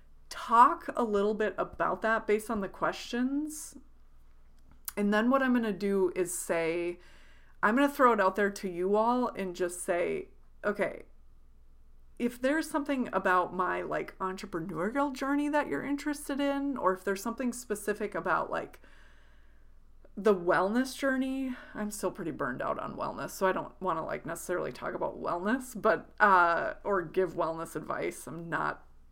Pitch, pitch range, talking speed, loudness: 200 Hz, 170-250 Hz, 165 wpm, -30 LUFS